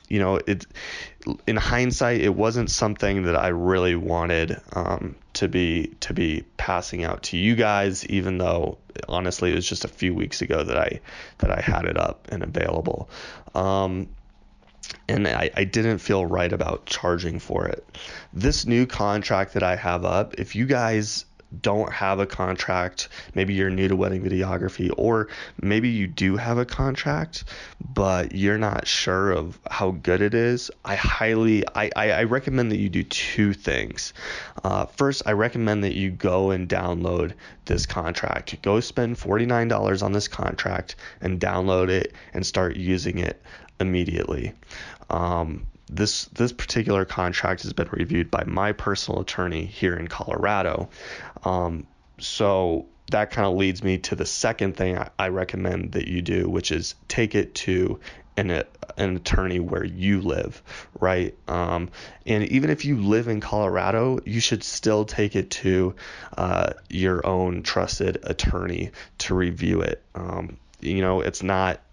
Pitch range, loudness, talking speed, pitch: 90-105 Hz, -24 LUFS, 165 wpm, 95 Hz